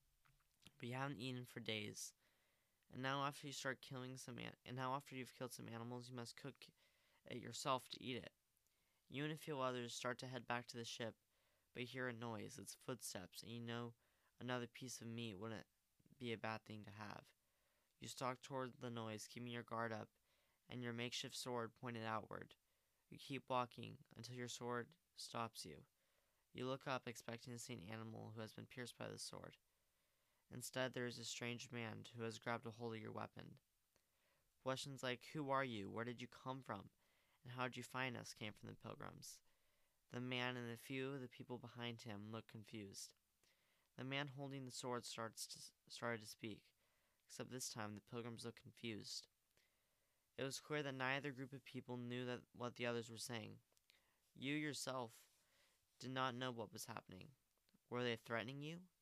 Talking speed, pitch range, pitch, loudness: 195 wpm, 115-130 Hz, 120 Hz, -50 LUFS